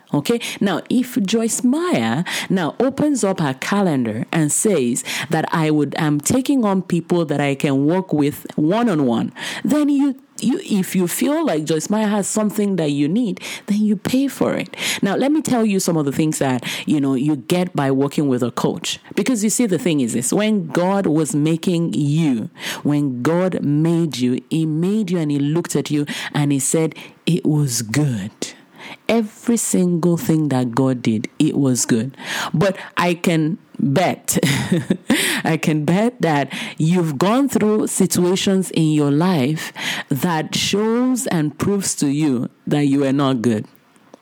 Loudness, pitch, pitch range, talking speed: -19 LUFS, 175 Hz, 145-215 Hz, 175 wpm